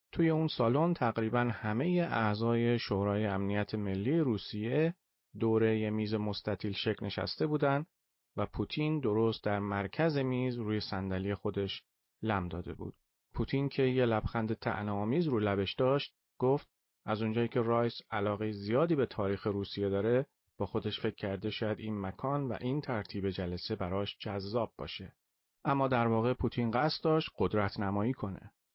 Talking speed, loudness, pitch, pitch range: 145 wpm, -33 LUFS, 110 Hz, 100-125 Hz